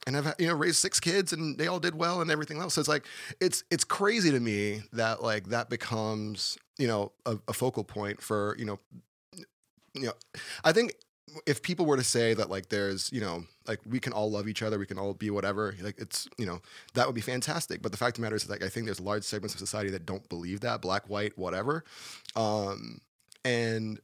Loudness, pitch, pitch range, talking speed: -31 LUFS, 110 Hz, 105-145 Hz, 240 wpm